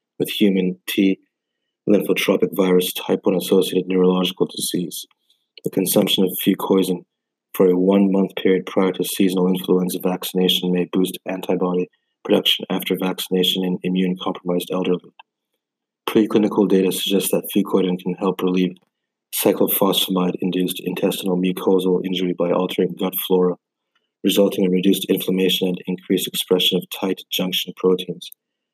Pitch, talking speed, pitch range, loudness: 90 Hz, 130 wpm, 90-95 Hz, -19 LUFS